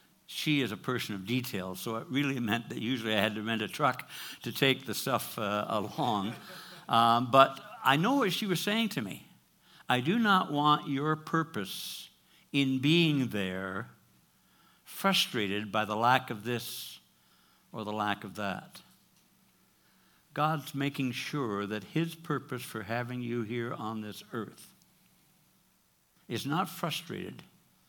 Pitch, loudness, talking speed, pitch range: 120 Hz, -31 LUFS, 150 wpm, 105-140 Hz